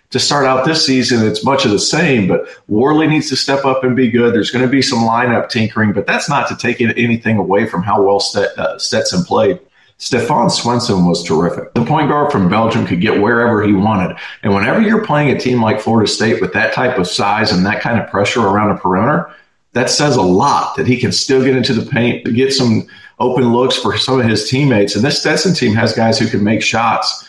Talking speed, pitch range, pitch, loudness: 235 wpm, 110-130 Hz, 120 Hz, -13 LUFS